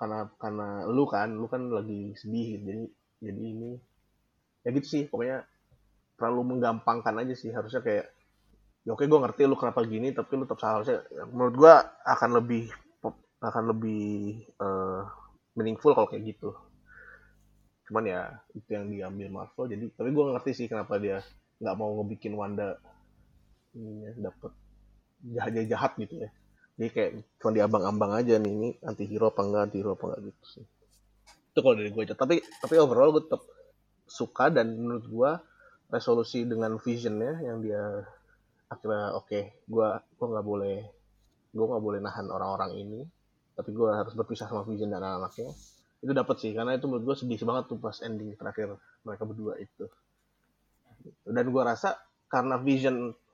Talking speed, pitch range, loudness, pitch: 165 wpm, 105-120 Hz, -29 LUFS, 110 Hz